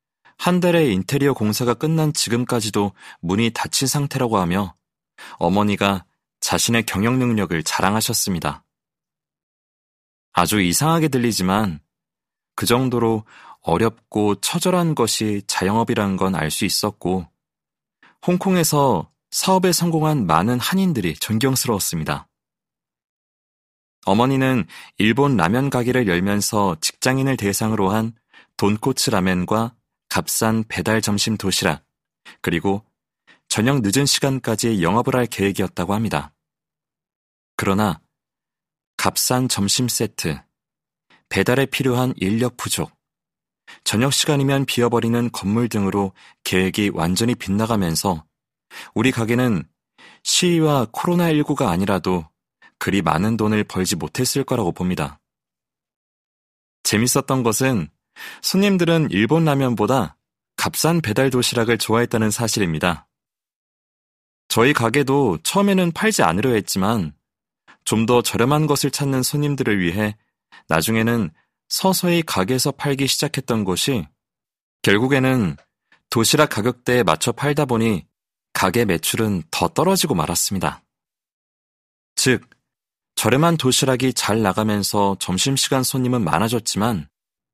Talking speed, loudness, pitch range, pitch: 265 characters per minute, -19 LUFS, 100-135 Hz, 115 Hz